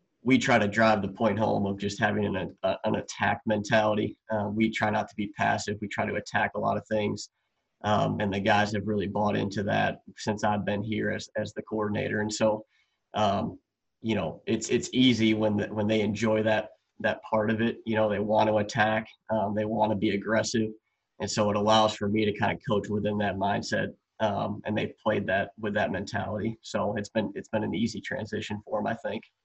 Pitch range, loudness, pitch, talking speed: 105-110 Hz, -28 LUFS, 105 Hz, 225 wpm